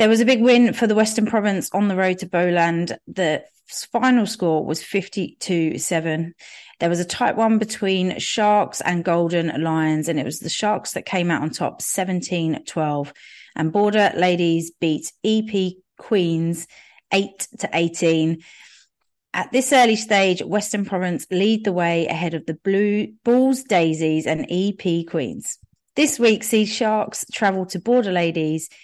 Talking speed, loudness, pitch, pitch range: 160 wpm, -20 LUFS, 185 Hz, 165-210 Hz